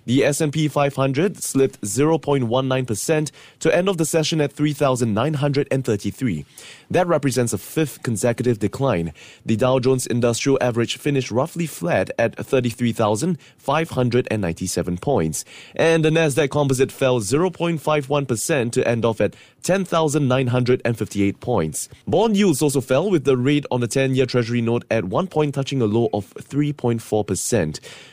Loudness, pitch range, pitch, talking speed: -20 LUFS, 115-150 Hz, 130 Hz, 135 wpm